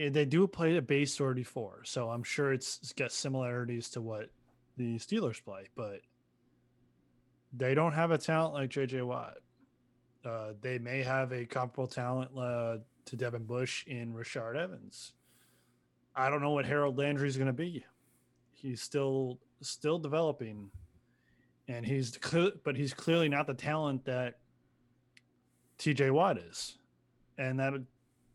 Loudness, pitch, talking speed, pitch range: -34 LUFS, 130 Hz, 145 wpm, 120-145 Hz